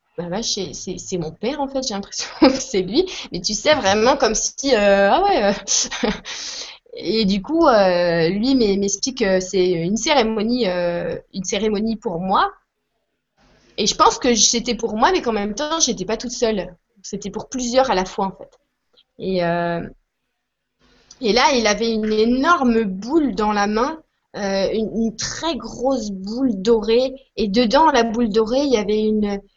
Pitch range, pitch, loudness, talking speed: 200-255 Hz, 220 Hz, -19 LUFS, 175 wpm